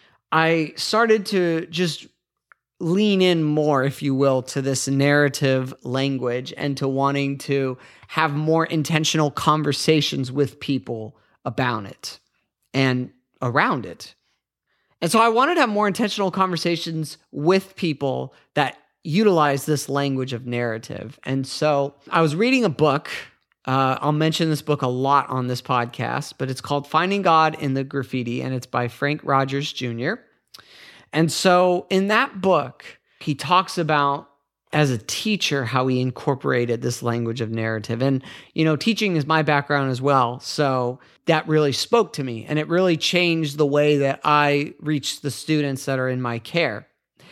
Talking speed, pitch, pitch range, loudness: 160 wpm, 145 Hz, 130-160 Hz, -21 LUFS